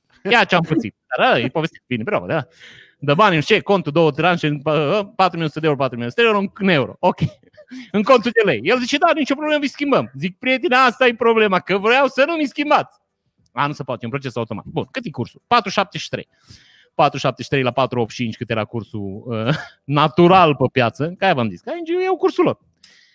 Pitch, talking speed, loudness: 180 Hz, 215 wpm, -18 LUFS